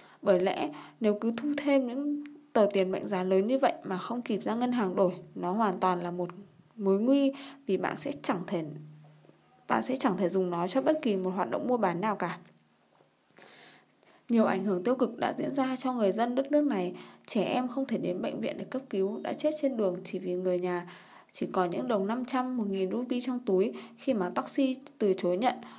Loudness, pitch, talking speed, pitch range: -30 LUFS, 210 Hz, 225 wpm, 185-260 Hz